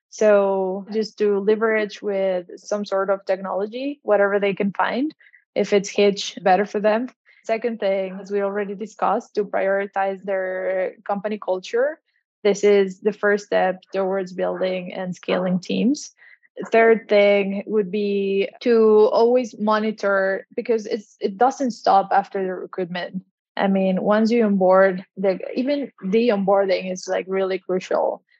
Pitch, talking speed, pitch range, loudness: 200 Hz, 145 wpm, 190-215 Hz, -21 LUFS